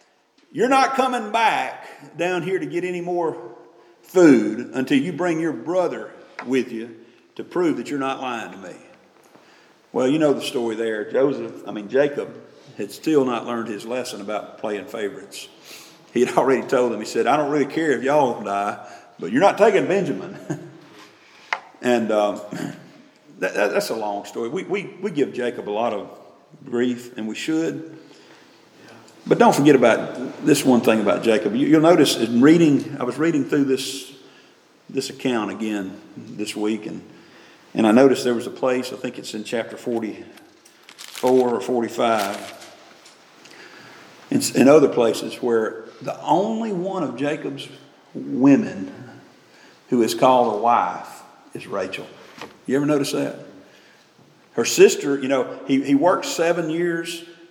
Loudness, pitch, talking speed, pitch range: -20 LUFS, 135 Hz, 160 wpm, 115-165 Hz